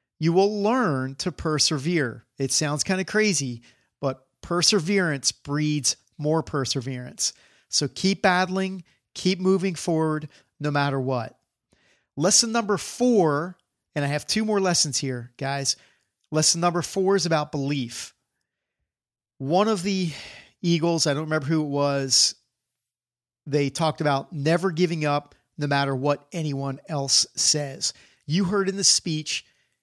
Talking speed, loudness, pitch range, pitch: 135 wpm, -23 LUFS, 140-185 Hz, 155 Hz